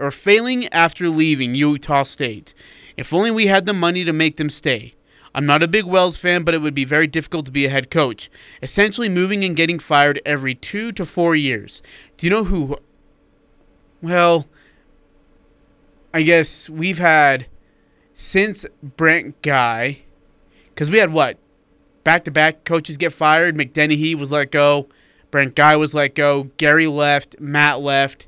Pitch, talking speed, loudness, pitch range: 155 Hz, 160 wpm, -16 LUFS, 145-170 Hz